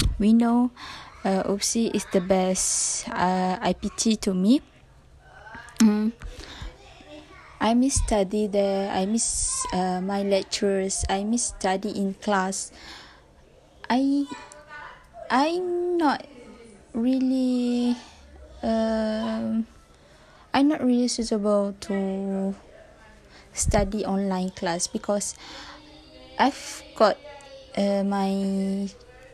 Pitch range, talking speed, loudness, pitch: 195-245 Hz, 90 wpm, -24 LUFS, 215 Hz